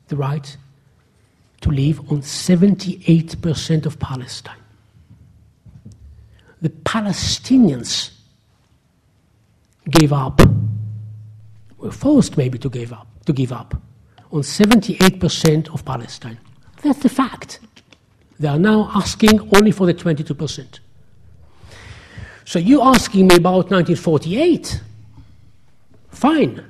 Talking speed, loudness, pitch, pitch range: 100 wpm, -16 LUFS, 140 Hz, 110-175 Hz